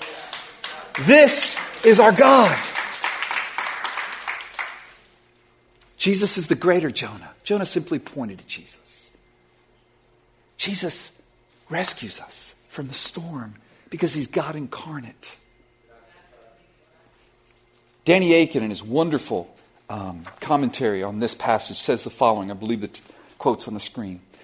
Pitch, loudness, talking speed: 140 Hz, -20 LUFS, 110 wpm